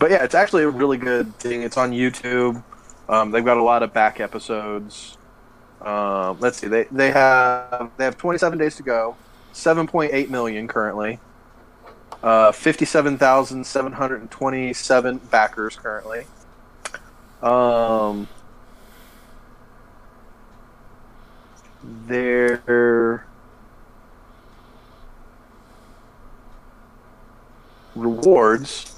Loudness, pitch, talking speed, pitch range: -19 LUFS, 120 Hz, 105 wpm, 115-130 Hz